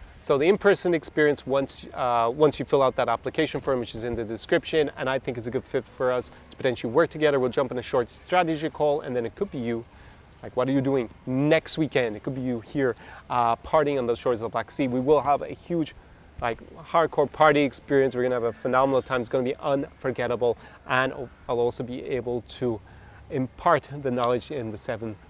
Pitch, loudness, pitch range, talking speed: 130 Hz, -25 LUFS, 120-145 Hz, 235 wpm